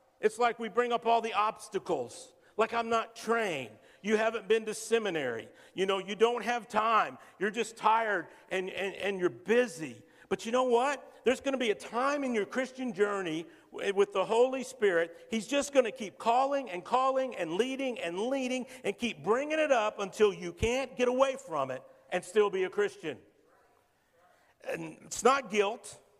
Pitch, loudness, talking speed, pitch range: 225 Hz, -31 LUFS, 190 wpm, 195-250 Hz